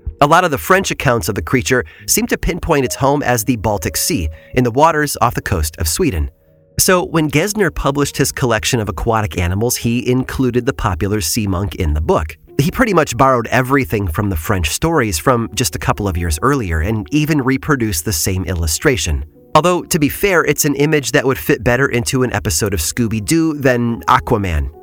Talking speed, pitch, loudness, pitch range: 205 wpm, 120 Hz, -15 LUFS, 95-145 Hz